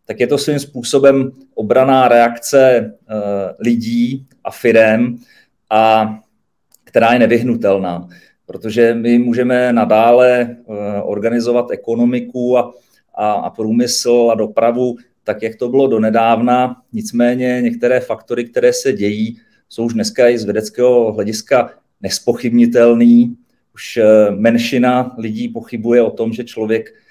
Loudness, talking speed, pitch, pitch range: -14 LUFS, 115 wpm, 120 Hz, 110-125 Hz